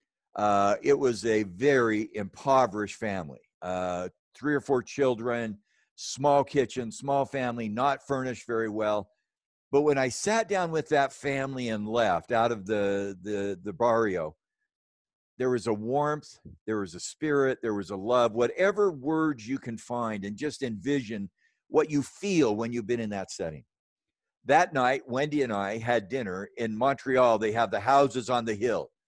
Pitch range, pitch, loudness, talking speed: 105-140 Hz, 120 Hz, -28 LUFS, 165 wpm